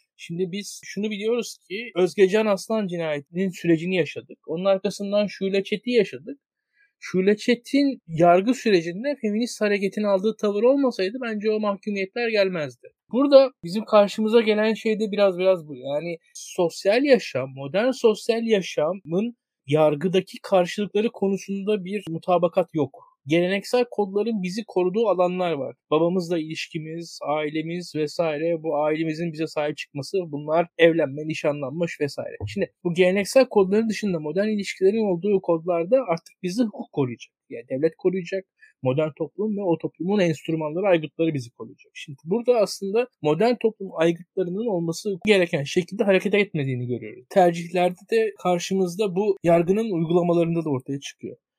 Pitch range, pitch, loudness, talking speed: 165-210 Hz, 190 Hz, -23 LUFS, 135 wpm